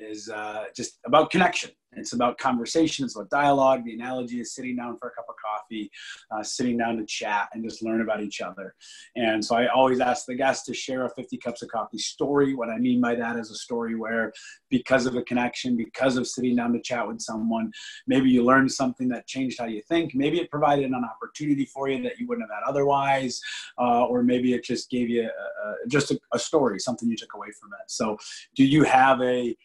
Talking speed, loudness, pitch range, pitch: 230 wpm, -25 LUFS, 115-135 Hz, 125 Hz